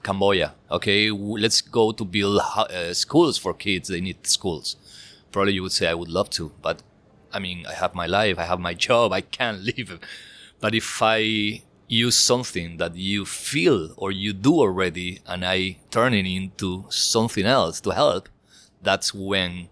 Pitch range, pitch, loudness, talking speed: 95-110 Hz, 100 Hz, -22 LUFS, 175 wpm